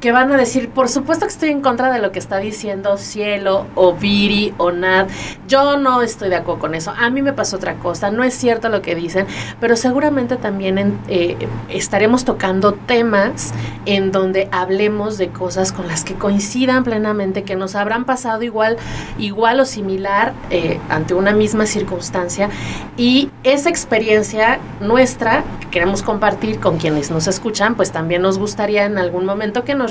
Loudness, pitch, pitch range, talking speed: -16 LUFS, 205 Hz, 190-235 Hz, 180 wpm